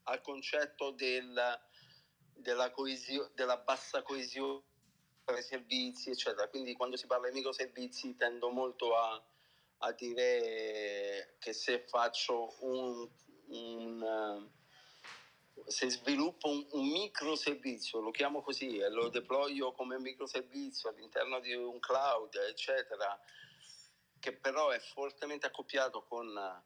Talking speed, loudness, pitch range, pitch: 115 wpm, -38 LUFS, 120-140 Hz, 130 Hz